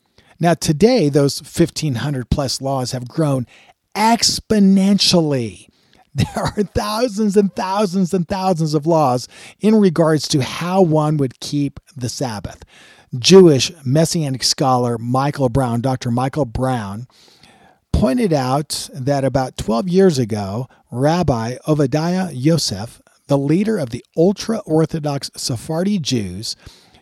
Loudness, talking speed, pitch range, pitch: -17 LUFS, 120 wpm, 130-175 Hz, 145 Hz